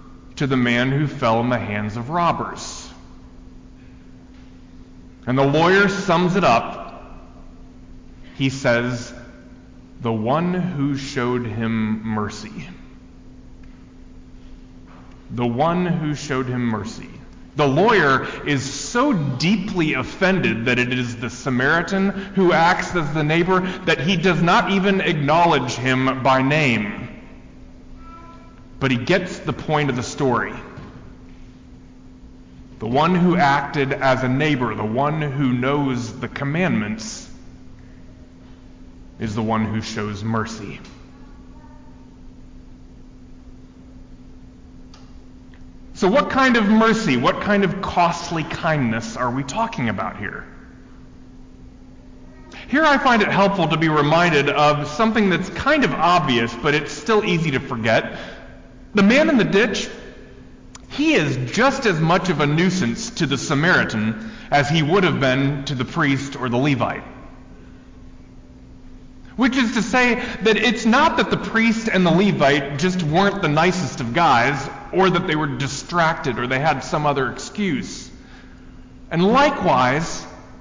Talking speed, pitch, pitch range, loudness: 130 wpm, 140 Hz, 120-185 Hz, -19 LUFS